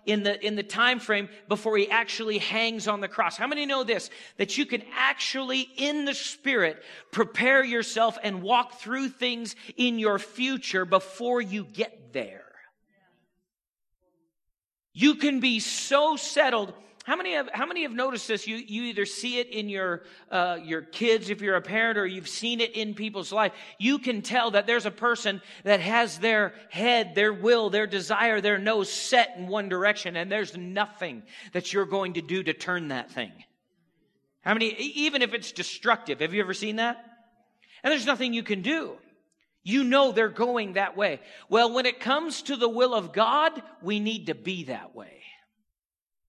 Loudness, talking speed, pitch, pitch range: -26 LUFS, 185 wpm, 220 Hz, 200-245 Hz